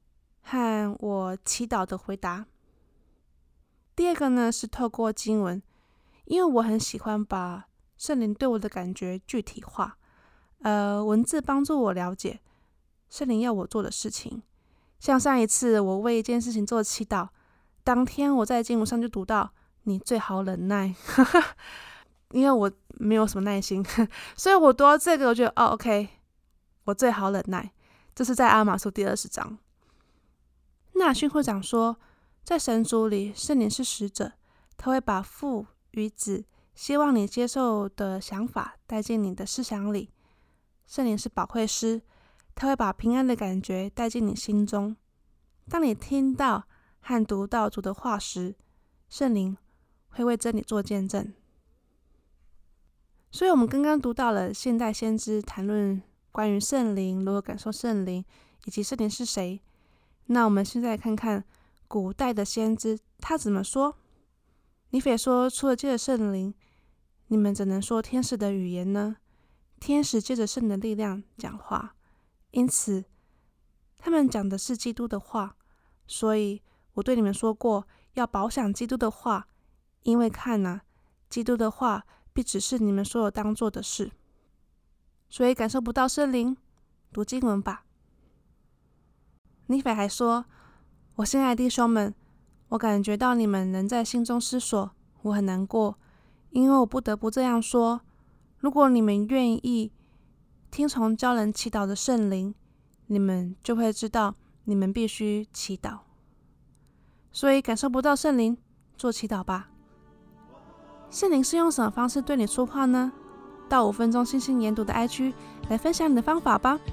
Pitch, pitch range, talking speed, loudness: 220 Hz, 200-250 Hz, 220 characters per minute, -26 LUFS